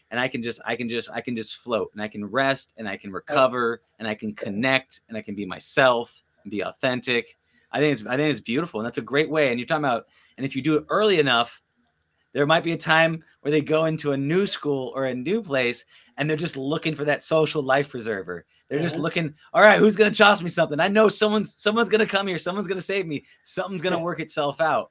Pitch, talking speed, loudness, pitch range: 145 Hz, 255 wpm, -23 LUFS, 125-170 Hz